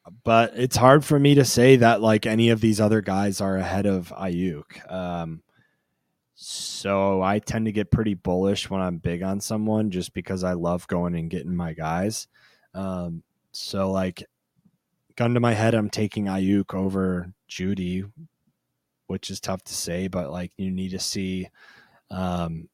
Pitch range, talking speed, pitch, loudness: 90-110 Hz, 170 wpm, 95 Hz, -23 LUFS